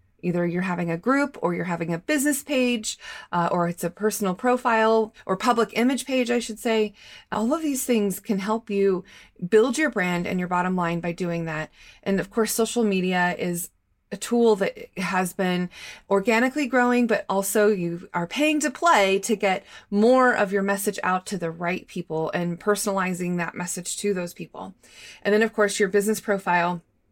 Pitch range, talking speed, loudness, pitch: 175-225 Hz, 190 wpm, -24 LUFS, 200 Hz